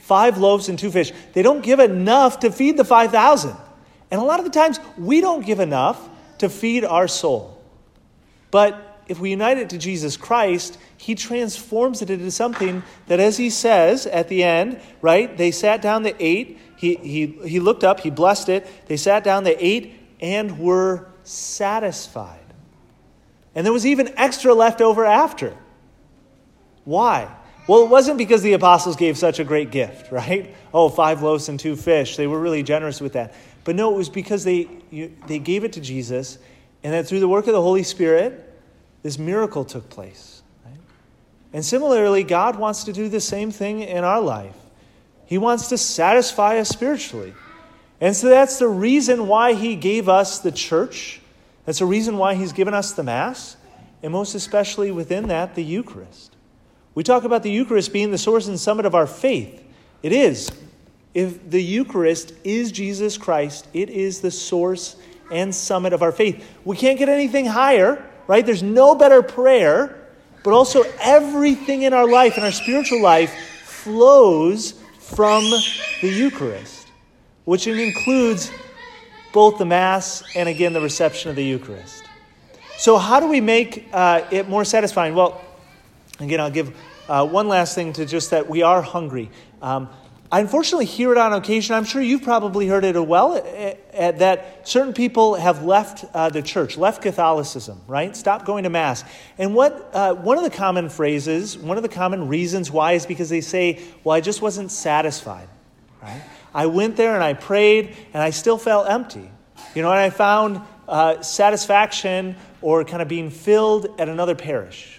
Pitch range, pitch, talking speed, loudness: 165-225 Hz, 195 Hz, 180 wpm, -18 LUFS